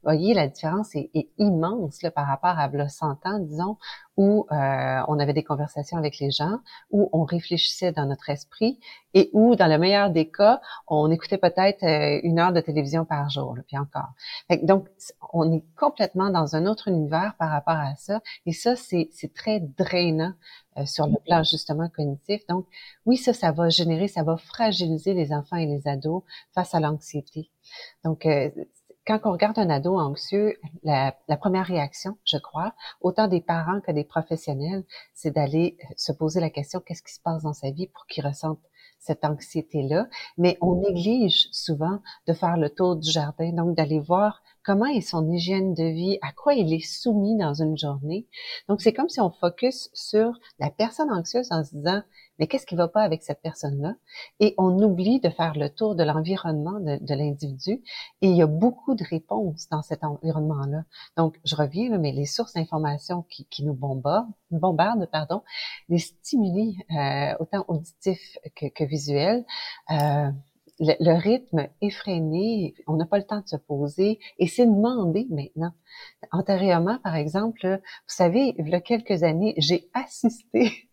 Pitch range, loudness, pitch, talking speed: 155-200 Hz, -25 LUFS, 170 Hz, 185 wpm